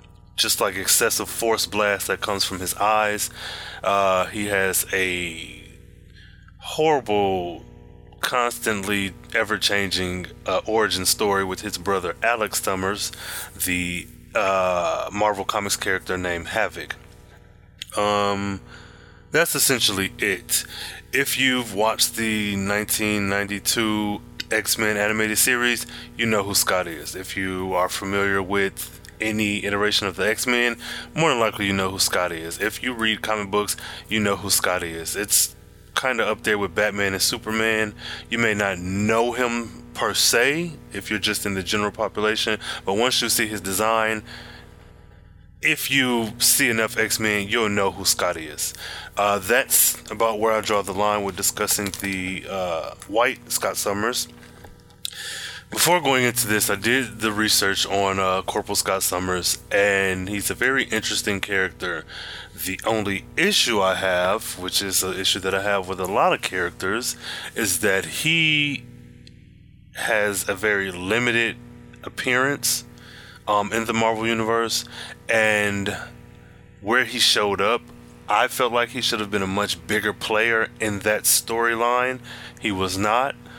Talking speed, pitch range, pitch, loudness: 150 wpm, 95-110 Hz, 105 Hz, -22 LUFS